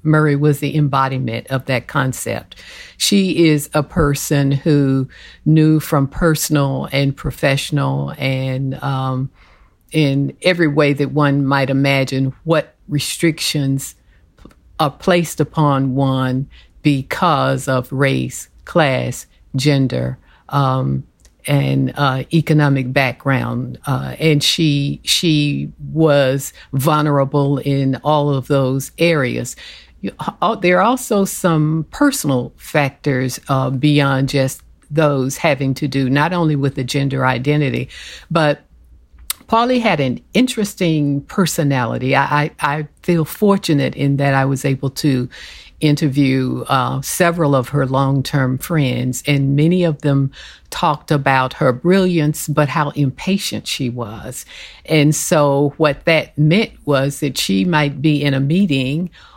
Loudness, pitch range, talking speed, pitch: -17 LUFS, 135-155 Hz, 125 wpm, 140 Hz